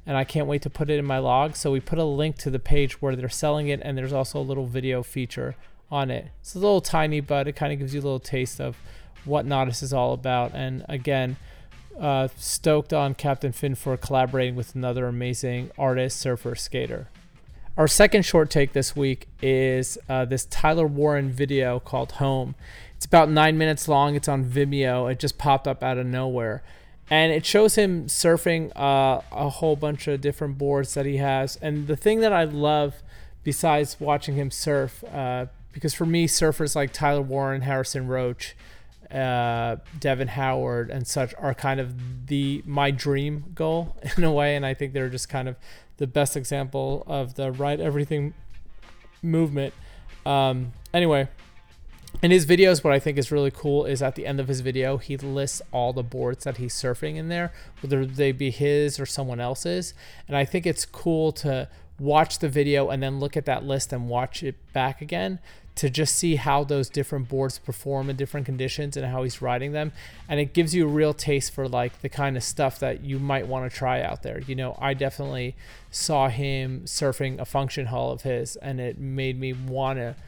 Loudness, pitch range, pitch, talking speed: -25 LUFS, 130-145 Hz, 140 Hz, 200 wpm